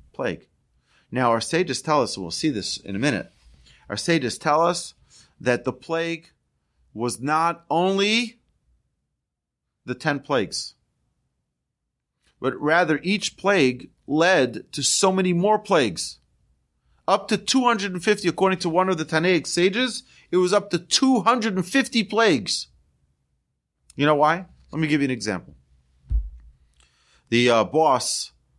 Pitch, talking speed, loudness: 155 Hz, 135 wpm, -22 LUFS